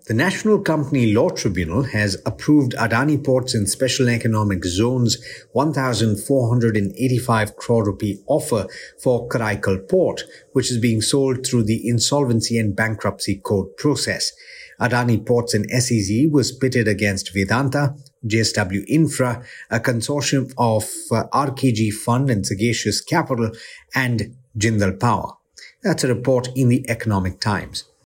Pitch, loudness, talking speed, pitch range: 120 Hz, -20 LUFS, 130 wpm, 110-130 Hz